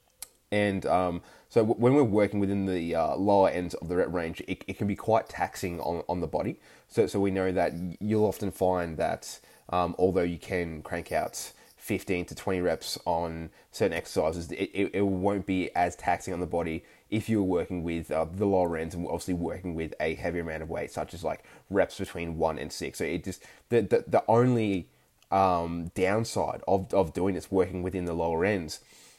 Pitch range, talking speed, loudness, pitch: 85-100 Hz, 205 wpm, -29 LUFS, 90 Hz